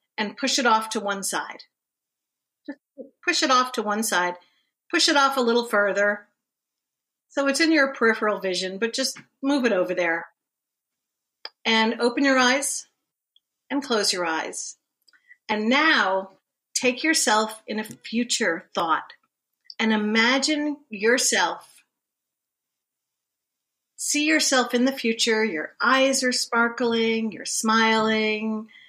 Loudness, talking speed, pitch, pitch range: -22 LUFS, 130 wpm, 235 Hz, 215-270 Hz